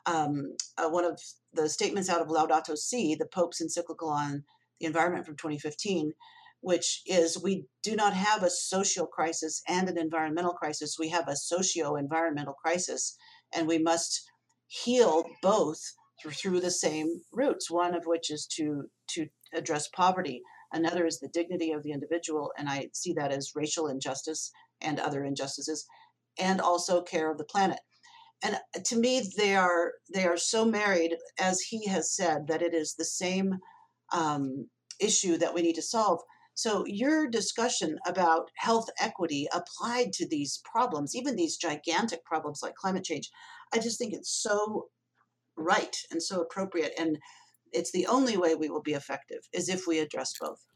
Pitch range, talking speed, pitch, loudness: 155-190 Hz, 170 wpm, 170 Hz, -30 LUFS